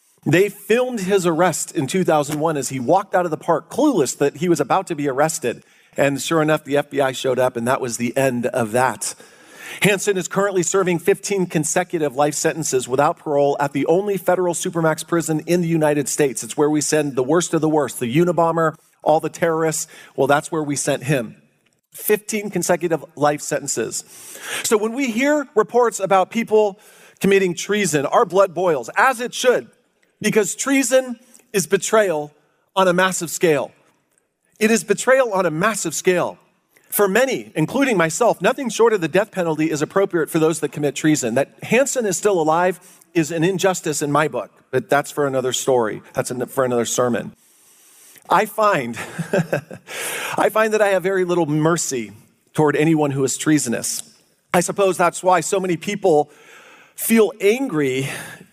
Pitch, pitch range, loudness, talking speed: 170 Hz, 150-200 Hz, -19 LUFS, 175 wpm